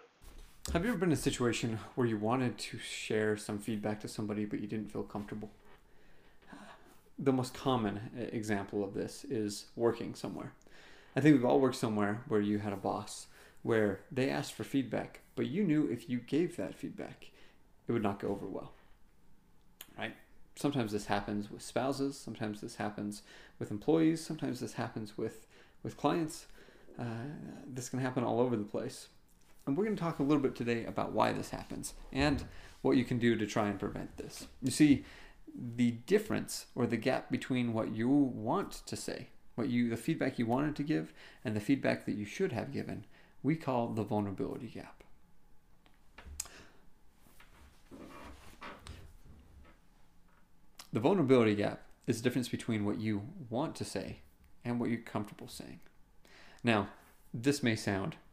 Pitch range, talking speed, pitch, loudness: 105-130 Hz, 170 wpm, 115 Hz, -35 LUFS